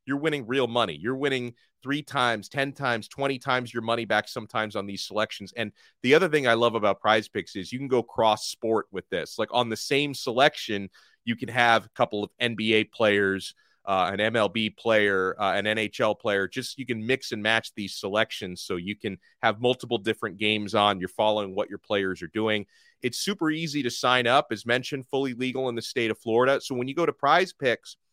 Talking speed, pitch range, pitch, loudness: 220 wpm, 105-130 Hz, 115 Hz, -26 LUFS